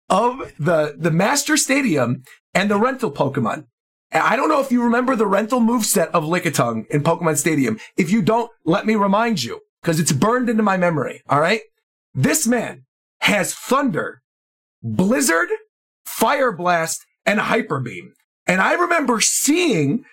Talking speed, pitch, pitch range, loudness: 160 wpm, 215 Hz, 165-250 Hz, -18 LUFS